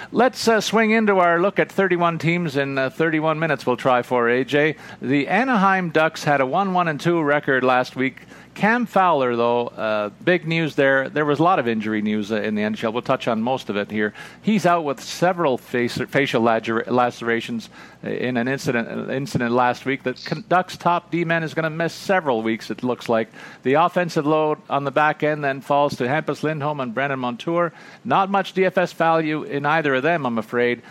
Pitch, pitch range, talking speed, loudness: 145 Hz, 125-170 Hz, 210 wpm, -20 LUFS